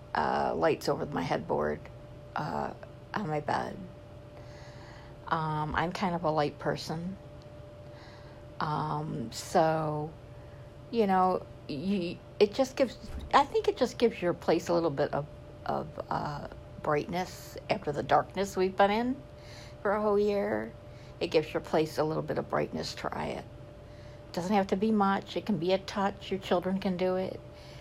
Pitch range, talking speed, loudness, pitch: 120-190 Hz, 160 wpm, -31 LUFS, 155 Hz